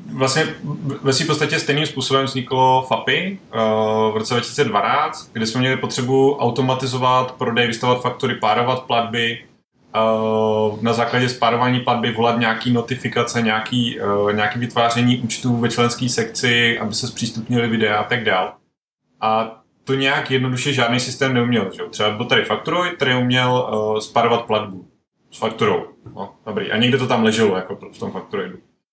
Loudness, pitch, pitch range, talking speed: -18 LUFS, 120 Hz, 115-130 Hz, 145 wpm